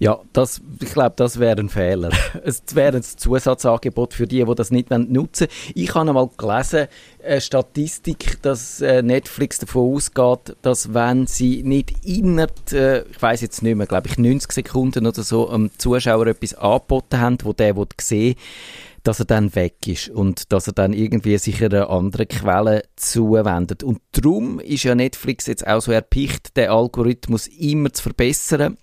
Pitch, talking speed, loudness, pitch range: 120 Hz, 175 wpm, -19 LUFS, 110-130 Hz